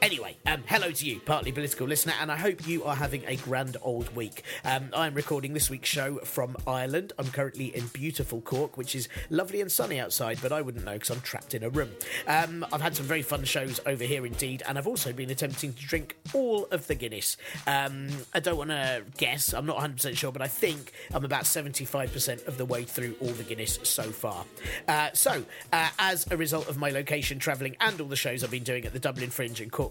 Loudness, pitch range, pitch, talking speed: -30 LUFS, 130-150 Hz, 140 Hz, 235 wpm